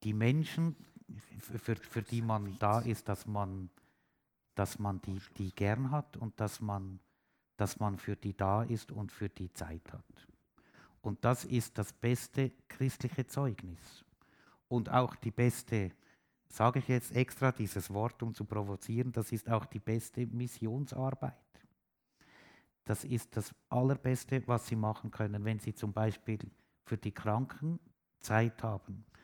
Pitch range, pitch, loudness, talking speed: 105-125 Hz, 110 Hz, -36 LUFS, 150 wpm